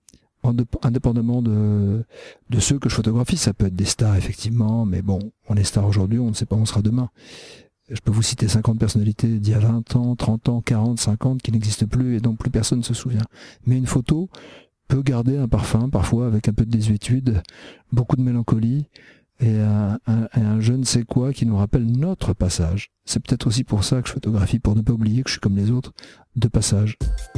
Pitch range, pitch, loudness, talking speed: 110-125 Hz, 115 Hz, -21 LUFS, 220 wpm